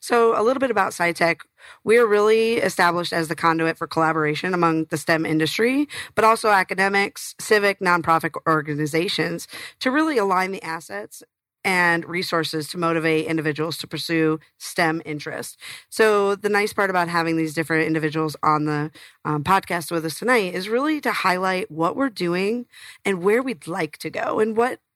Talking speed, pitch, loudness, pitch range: 165 wpm, 170 Hz, -21 LUFS, 160-205 Hz